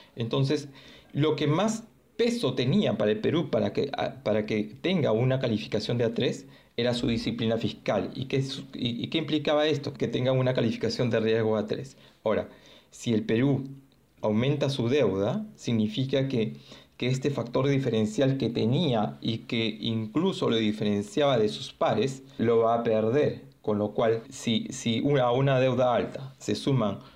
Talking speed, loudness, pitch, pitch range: 165 wpm, -27 LUFS, 125 Hz, 110-140 Hz